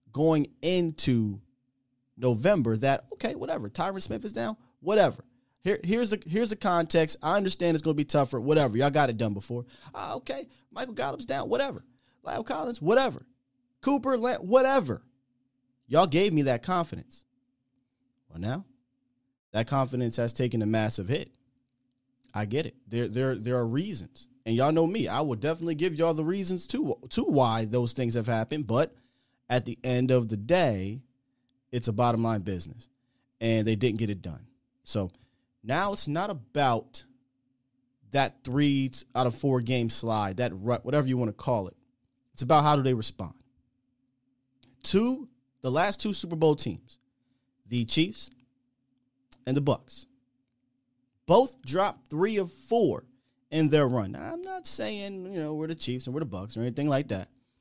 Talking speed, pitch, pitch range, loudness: 170 wpm, 130 Hz, 125-155 Hz, -28 LUFS